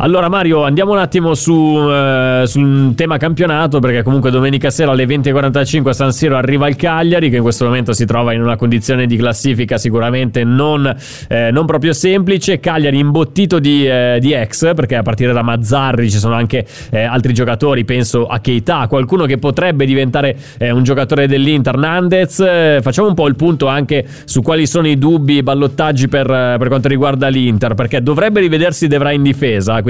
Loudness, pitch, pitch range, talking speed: -12 LUFS, 140 Hz, 125-155 Hz, 190 wpm